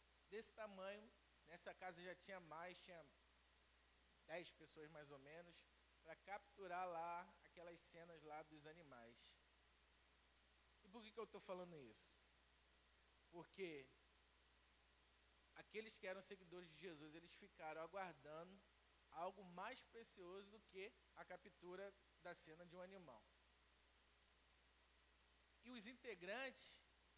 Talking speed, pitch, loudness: 120 wpm, 160 Hz, -58 LUFS